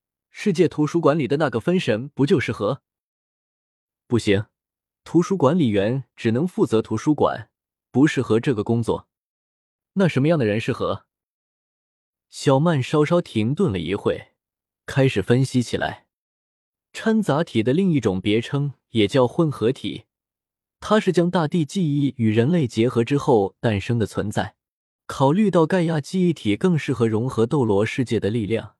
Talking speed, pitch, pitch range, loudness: 235 characters per minute, 135 Hz, 110-165 Hz, -21 LUFS